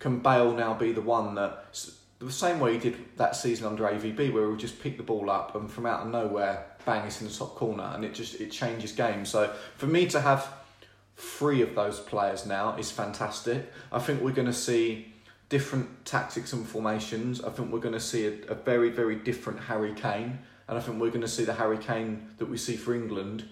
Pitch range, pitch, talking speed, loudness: 105-120 Hz, 115 Hz, 230 wpm, -30 LUFS